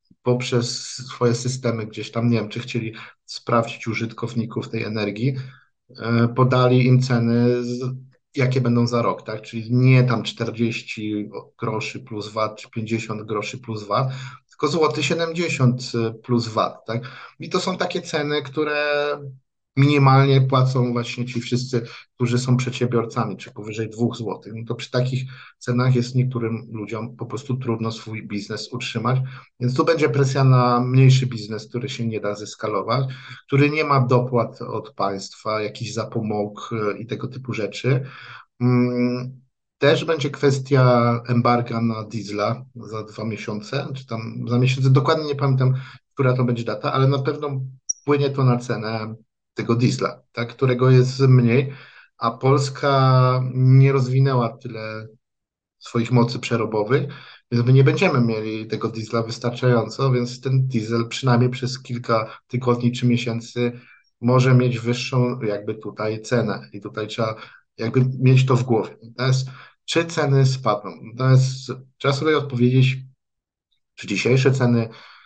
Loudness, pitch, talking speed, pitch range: -21 LUFS, 120 Hz, 140 wpm, 115-130 Hz